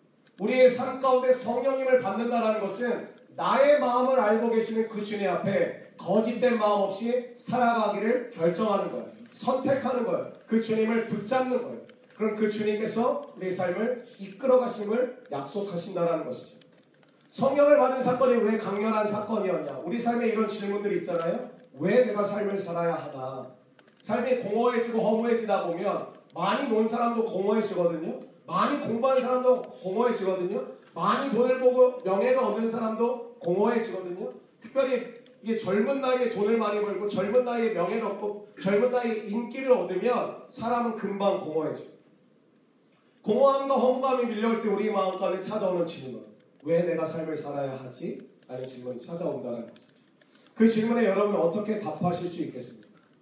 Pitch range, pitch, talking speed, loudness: 195-245 Hz, 220 Hz, 350 characters per minute, -27 LUFS